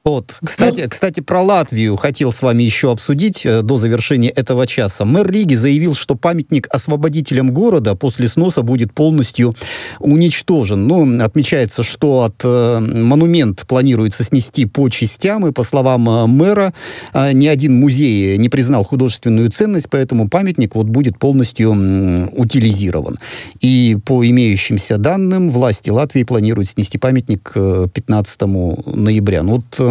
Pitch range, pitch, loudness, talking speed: 110-145 Hz, 125 Hz, -13 LUFS, 130 wpm